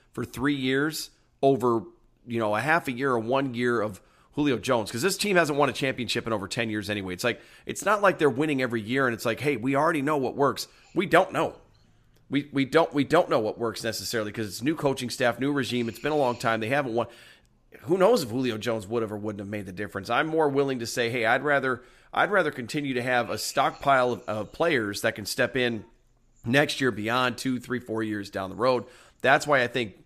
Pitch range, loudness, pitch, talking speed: 115-140 Hz, -26 LUFS, 125 Hz, 245 wpm